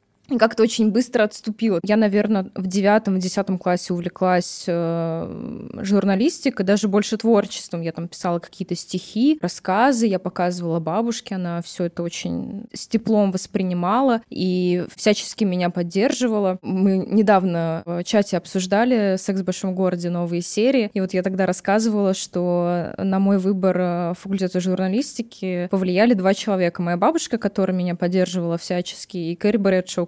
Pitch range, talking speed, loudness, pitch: 180-215 Hz, 140 wpm, -21 LUFS, 190 Hz